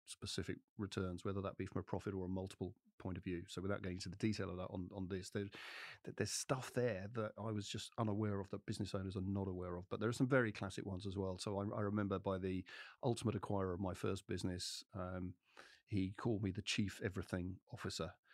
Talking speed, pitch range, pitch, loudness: 230 wpm, 95-105 Hz, 100 Hz, -43 LUFS